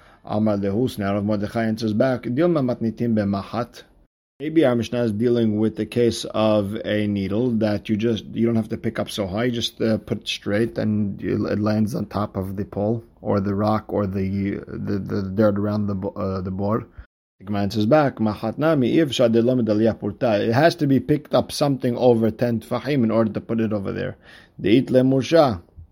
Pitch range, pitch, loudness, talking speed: 105-120 Hz, 110 Hz, -22 LUFS, 165 wpm